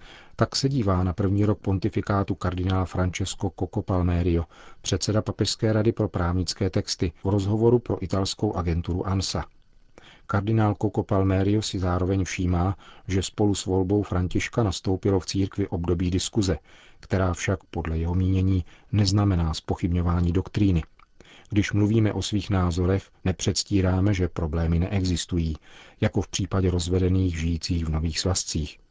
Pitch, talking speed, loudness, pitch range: 95 Hz, 135 wpm, -25 LUFS, 90-100 Hz